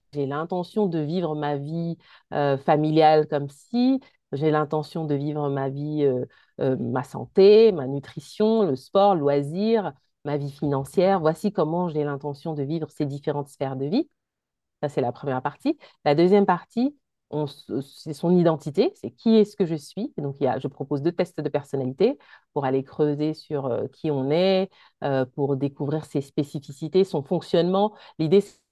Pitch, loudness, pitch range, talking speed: 155 Hz, -24 LUFS, 140-185 Hz, 175 wpm